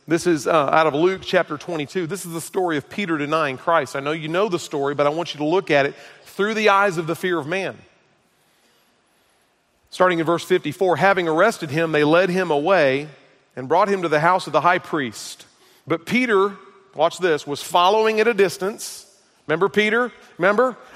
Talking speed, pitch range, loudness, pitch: 205 wpm, 150-195 Hz, -20 LUFS, 175 Hz